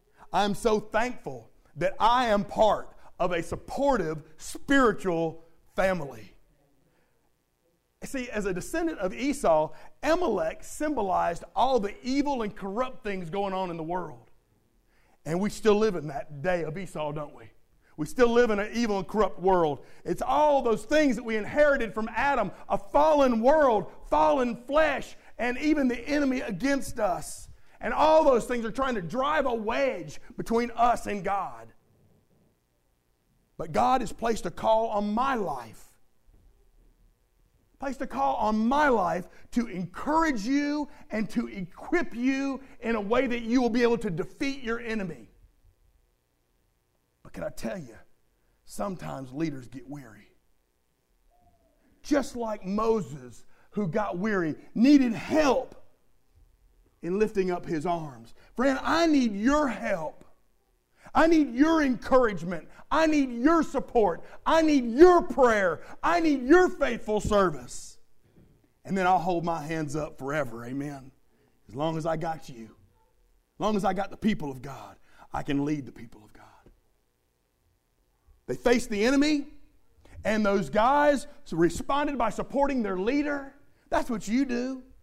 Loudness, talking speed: -27 LUFS, 150 wpm